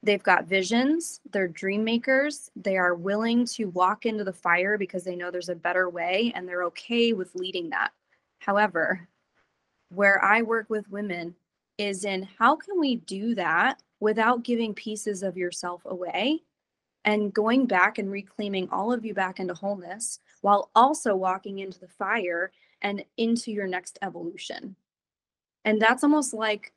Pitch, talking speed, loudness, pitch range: 205 Hz, 160 wpm, -26 LUFS, 185-230 Hz